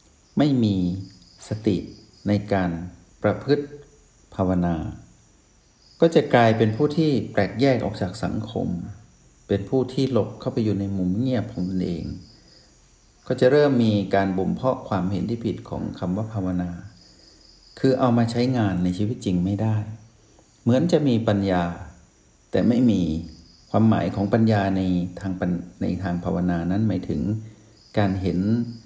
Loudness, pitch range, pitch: -23 LUFS, 90-115 Hz, 100 Hz